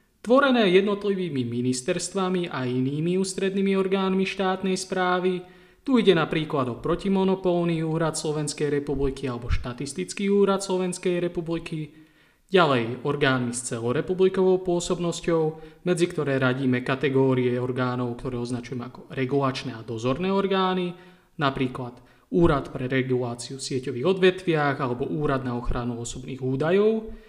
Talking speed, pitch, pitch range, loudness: 115 wpm, 155 Hz, 130-185 Hz, -25 LUFS